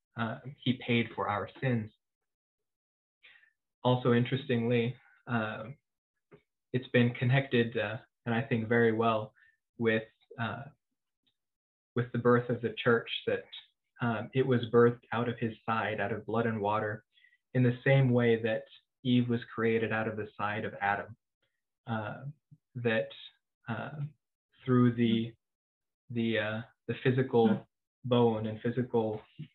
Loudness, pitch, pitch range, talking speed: -31 LUFS, 120 Hz, 110-125 Hz, 135 wpm